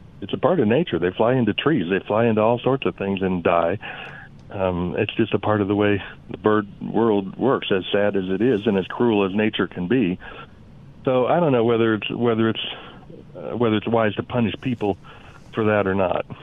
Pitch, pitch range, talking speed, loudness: 105 Hz, 100-115 Hz, 225 wpm, -21 LUFS